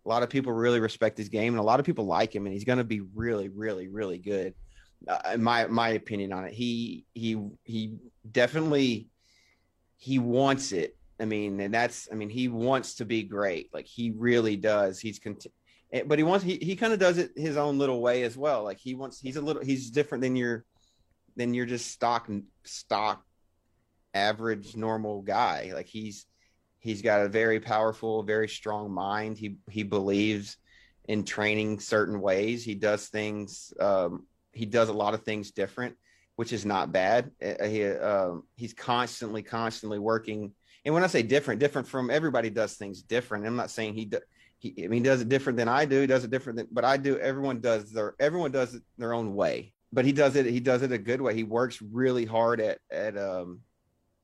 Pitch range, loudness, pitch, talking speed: 105-125 Hz, -29 LUFS, 115 Hz, 205 wpm